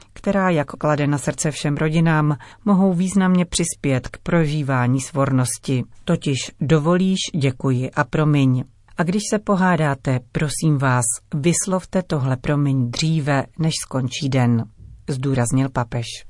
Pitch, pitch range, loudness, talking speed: 145 Hz, 130-170 Hz, -20 LUFS, 120 wpm